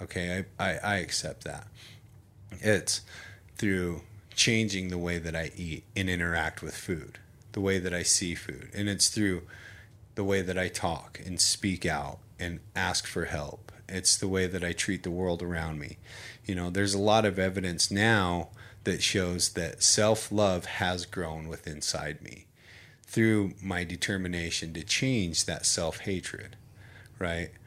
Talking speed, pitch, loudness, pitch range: 165 wpm, 95 Hz, -29 LUFS, 90-105 Hz